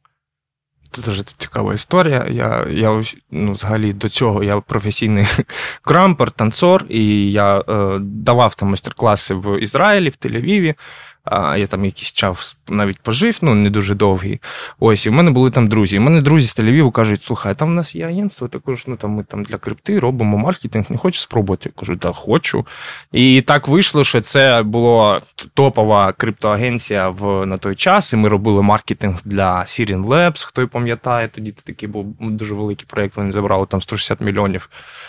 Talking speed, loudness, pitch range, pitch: 180 wpm, -15 LUFS, 100-130 Hz, 110 Hz